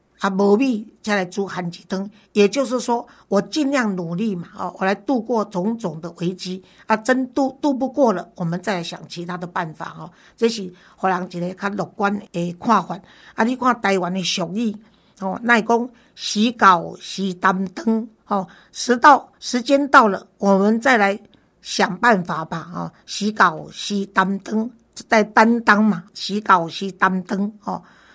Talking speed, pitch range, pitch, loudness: 230 characters per minute, 185-230 Hz, 200 Hz, -20 LUFS